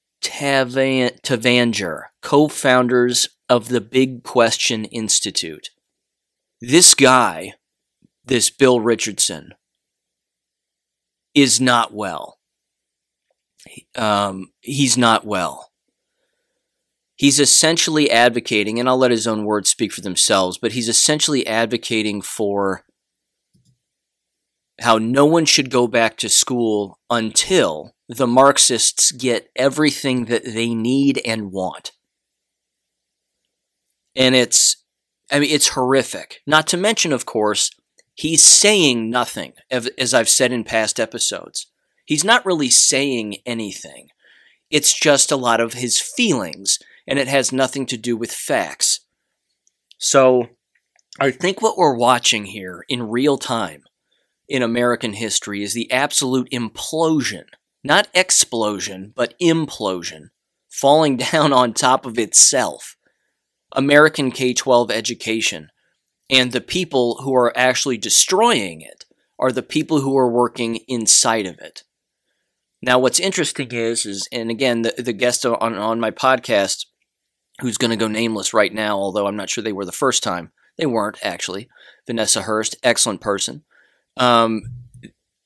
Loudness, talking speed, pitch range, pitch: -16 LUFS, 125 wpm, 115-135 Hz, 125 Hz